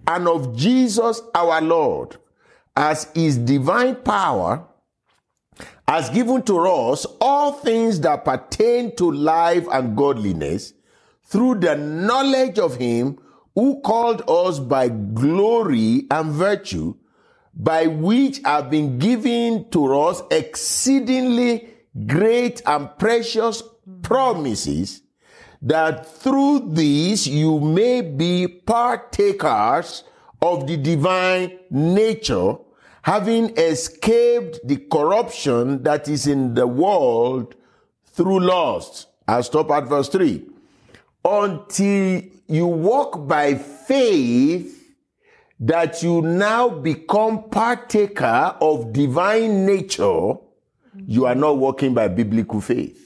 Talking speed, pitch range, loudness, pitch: 105 wpm, 150-235 Hz, -19 LUFS, 185 Hz